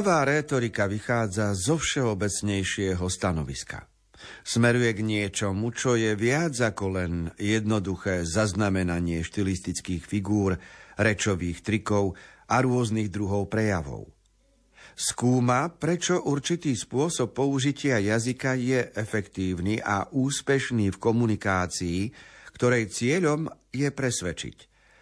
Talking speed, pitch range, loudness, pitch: 95 wpm, 95-125 Hz, -26 LUFS, 110 Hz